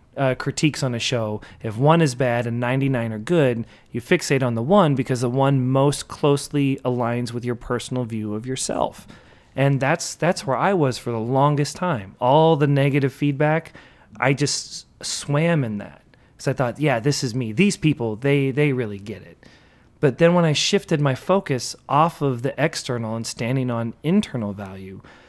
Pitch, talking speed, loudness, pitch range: 135 Hz, 180 wpm, -21 LUFS, 120-150 Hz